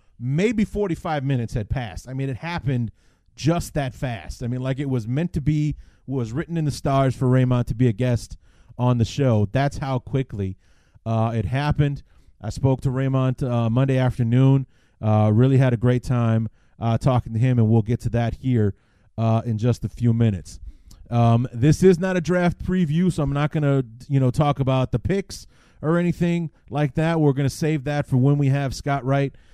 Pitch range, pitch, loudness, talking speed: 115-145 Hz, 130 Hz, -22 LUFS, 205 wpm